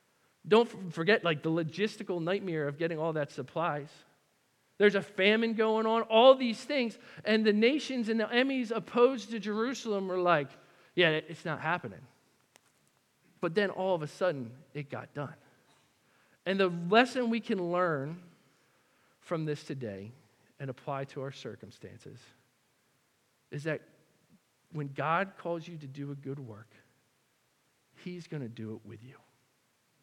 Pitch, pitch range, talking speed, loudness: 170 Hz, 140-210 Hz, 150 wpm, -30 LUFS